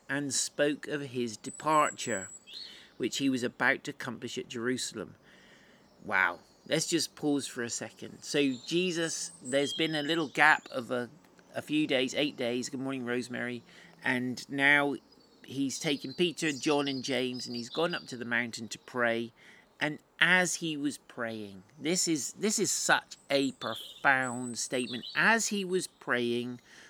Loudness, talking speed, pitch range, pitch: -30 LUFS, 160 wpm, 125-155 Hz, 135 Hz